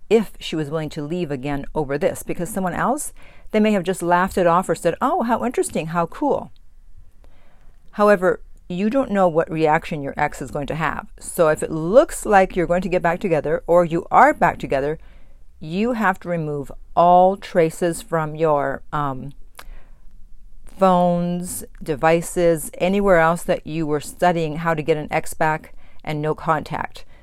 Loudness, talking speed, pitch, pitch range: -20 LUFS, 175 wpm, 170 Hz, 155-185 Hz